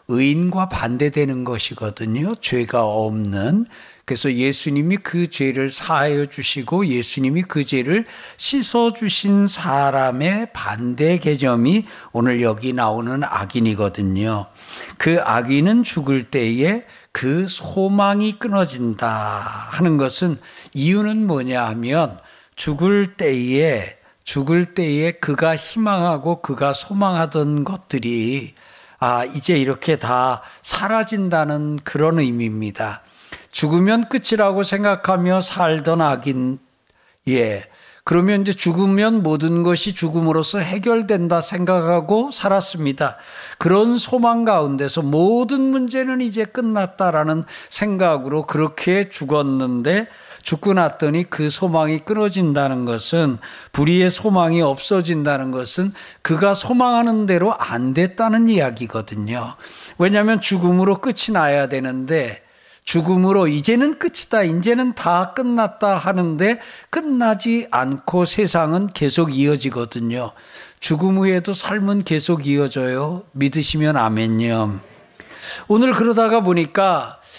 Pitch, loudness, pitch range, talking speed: 165 Hz, -18 LUFS, 135-200 Hz, 260 characters per minute